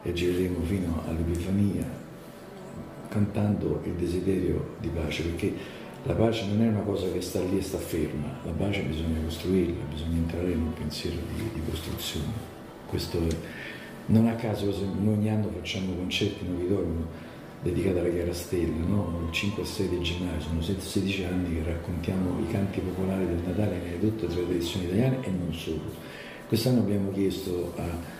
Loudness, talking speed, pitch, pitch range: -29 LUFS, 170 wpm, 90 Hz, 85-100 Hz